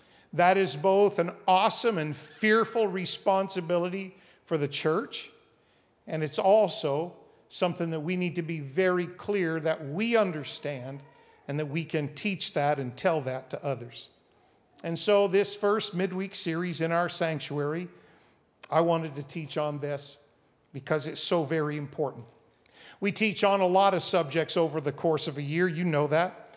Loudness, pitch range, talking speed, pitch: -28 LUFS, 150-190 Hz, 165 wpm, 165 Hz